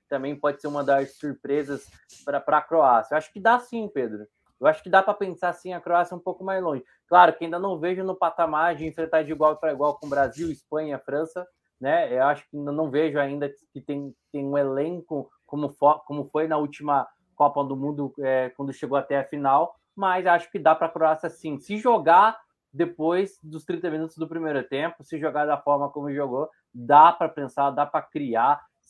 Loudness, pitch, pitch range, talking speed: -24 LUFS, 155 Hz, 140-170 Hz, 215 wpm